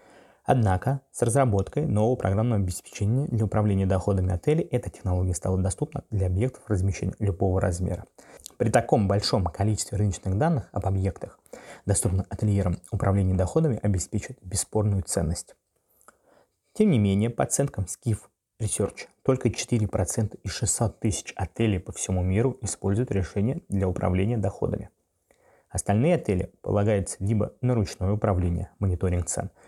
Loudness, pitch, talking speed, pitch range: -26 LUFS, 100 Hz, 130 wpm, 95-115 Hz